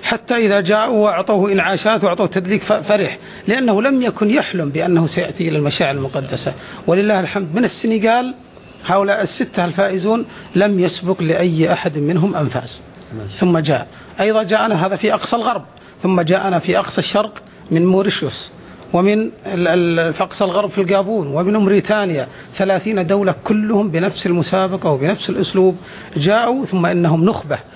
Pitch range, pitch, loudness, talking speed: 175-210 Hz, 190 Hz, -16 LUFS, 135 wpm